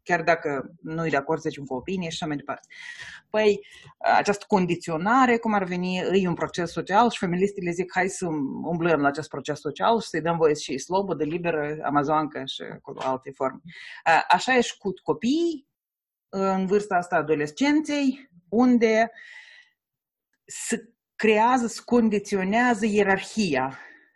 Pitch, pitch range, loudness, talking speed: 190 Hz, 160-225 Hz, -24 LUFS, 155 wpm